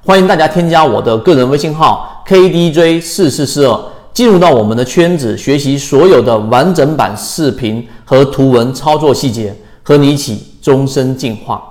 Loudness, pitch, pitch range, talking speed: -10 LUFS, 135 Hz, 115-160 Hz, 270 characters per minute